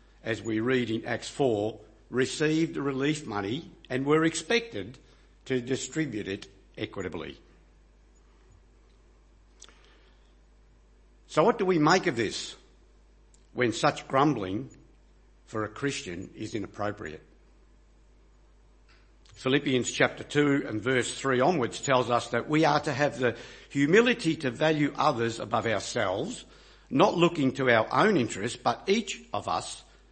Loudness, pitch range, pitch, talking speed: -28 LUFS, 110-150 Hz, 130 Hz, 125 wpm